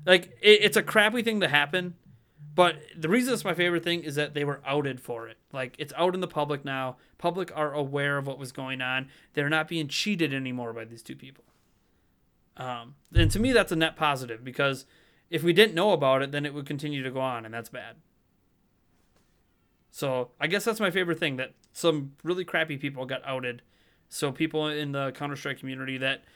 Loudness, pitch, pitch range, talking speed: -27 LUFS, 145 Hz, 130-170 Hz, 210 wpm